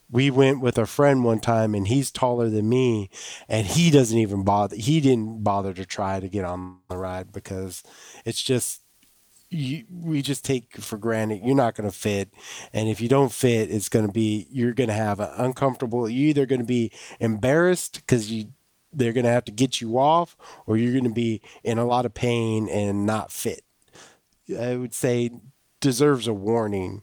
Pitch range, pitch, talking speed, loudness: 105-130 Hz, 115 Hz, 200 wpm, -23 LUFS